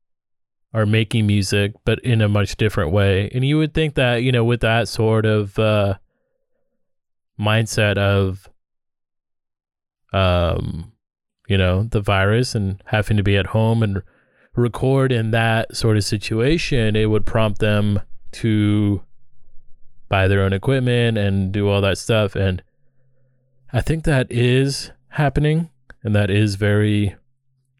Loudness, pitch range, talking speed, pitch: -19 LUFS, 100-125 Hz, 140 wpm, 110 Hz